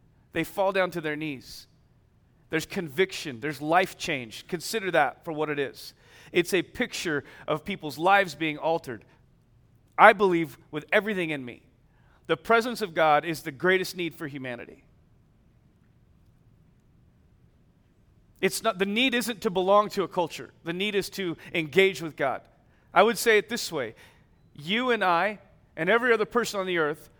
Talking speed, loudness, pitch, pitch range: 165 wpm, -26 LUFS, 165 Hz, 145-195 Hz